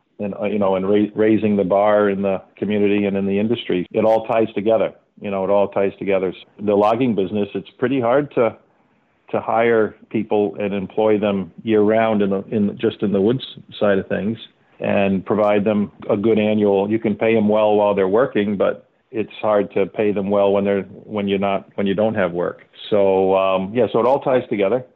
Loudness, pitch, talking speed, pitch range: -19 LUFS, 100 Hz, 215 wpm, 100-105 Hz